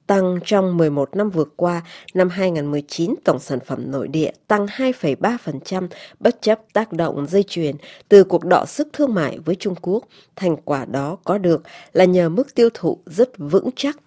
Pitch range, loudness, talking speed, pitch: 165-210 Hz, -19 LUFS, 185 wpm, 185 Hz